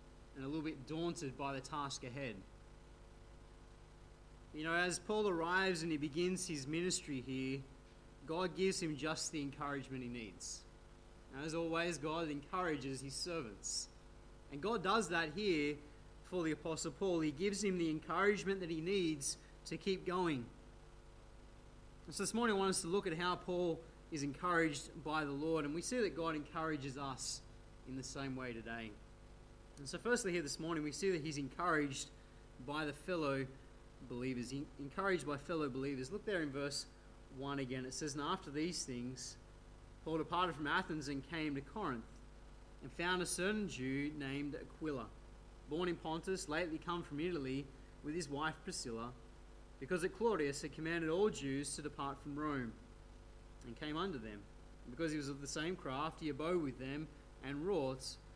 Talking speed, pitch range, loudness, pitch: 175 wpm, 135-170 Hz, -41 LUFS, 150 Hz